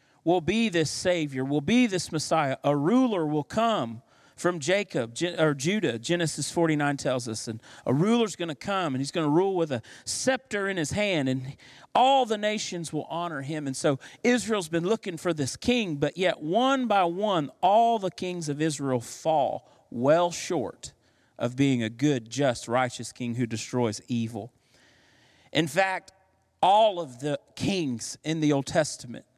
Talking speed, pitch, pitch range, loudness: 170 wpm, 155 Hz, 135-185 Hz, -27 LUFS